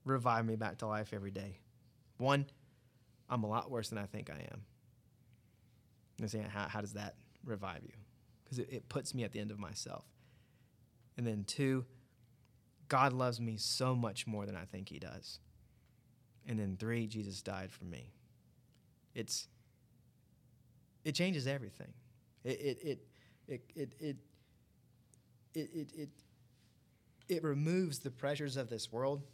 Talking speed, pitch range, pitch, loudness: 155 wpm, 110-130 Hz, 120 Hz, -40 LUFS